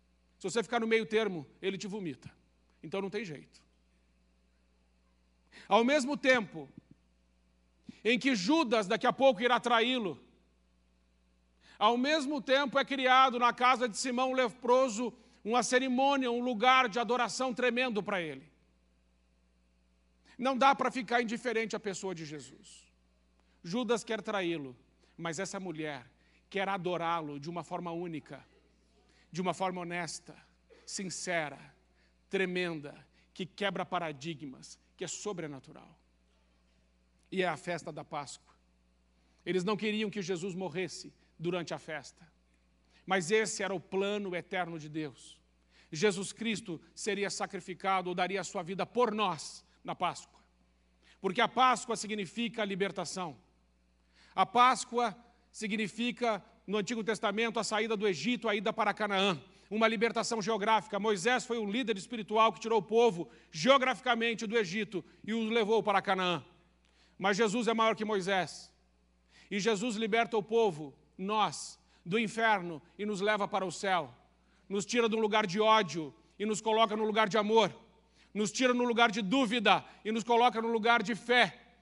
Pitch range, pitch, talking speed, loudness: 155-230 Hz, 195 Hz, 145 wpm, -31 LUFS